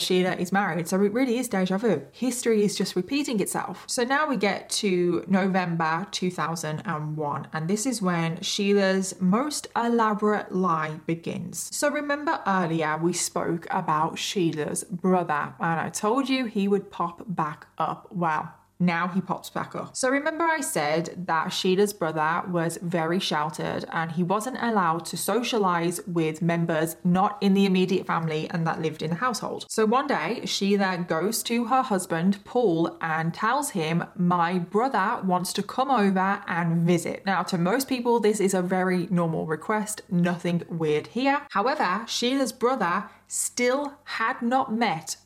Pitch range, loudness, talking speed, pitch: 170-220 Hz, -25 LUFS, 160 wpm, 190 Hz